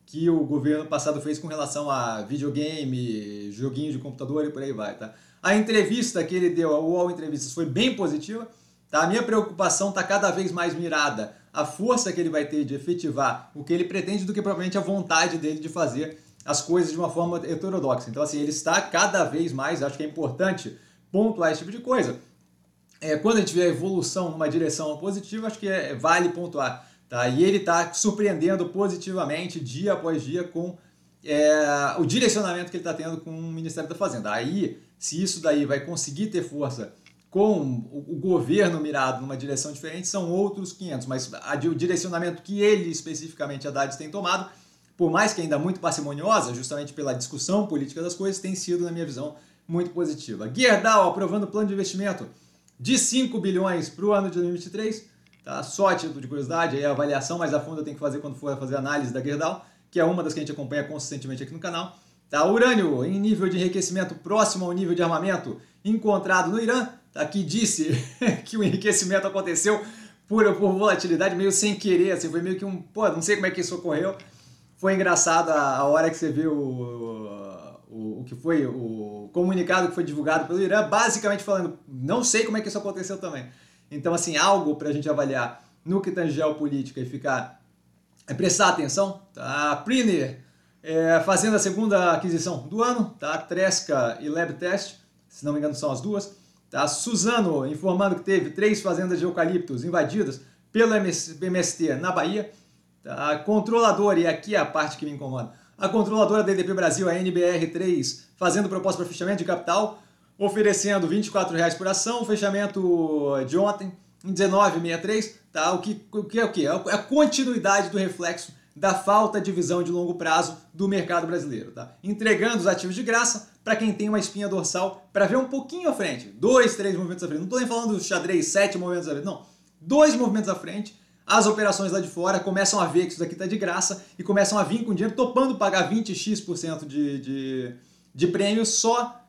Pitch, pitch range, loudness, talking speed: 175 Hz, 150-200 Hz, -24 LUFS, 195 wpm